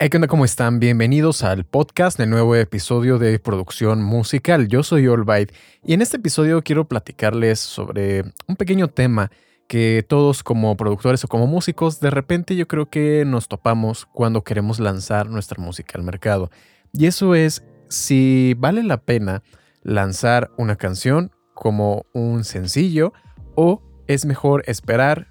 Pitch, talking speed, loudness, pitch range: 120 Hz, 150 wpm, -18 LUFS, 105-150 Hz